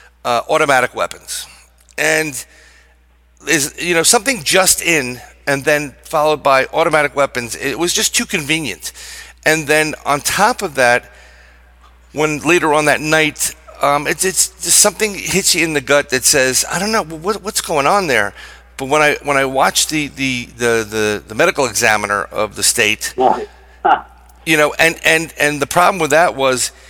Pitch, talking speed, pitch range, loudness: 155 Hz, 175 wpm, 135-175 Hz, -14 LUFS